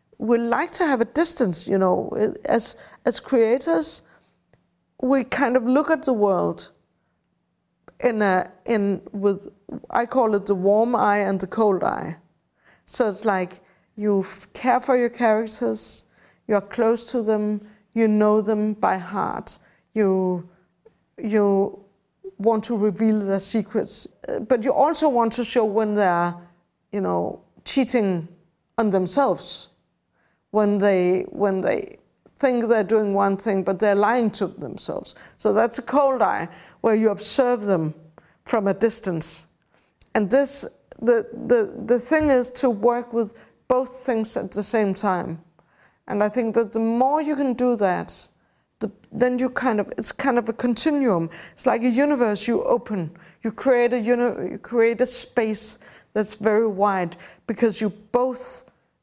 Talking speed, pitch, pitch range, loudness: 155 wpm, 220 Hz, 195-245 Hz, -22 LUFS